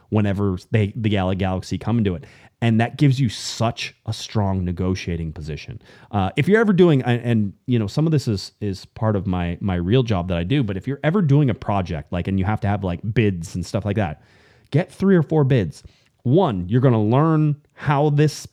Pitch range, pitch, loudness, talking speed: 95-135 Hz, 110 Hz, -21 LUFS, 225 wpm